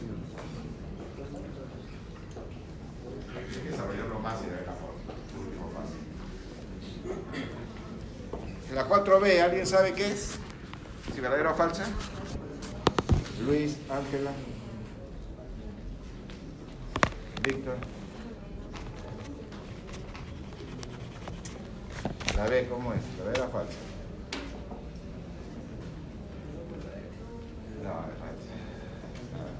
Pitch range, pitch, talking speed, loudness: 110-155 Hz, 125 Hz, 65 wpm, -33 LUFS